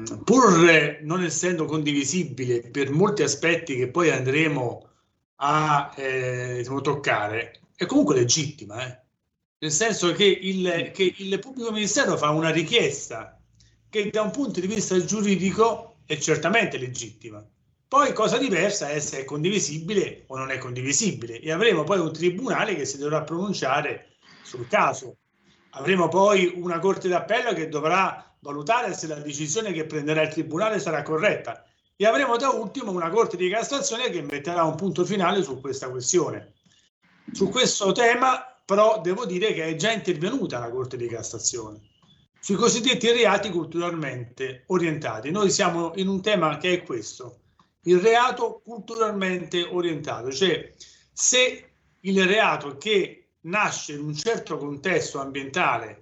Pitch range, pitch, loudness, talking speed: 145-200 Hz, 170 Hz, -23 LUFS, 145 wpm